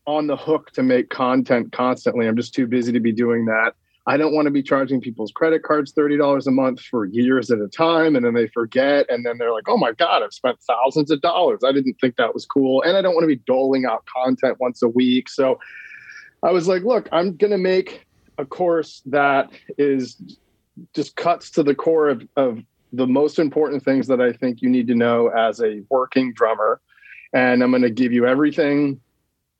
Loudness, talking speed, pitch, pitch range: -19 LUFS, 220 wpm, 130 Hz, 125-150 Hz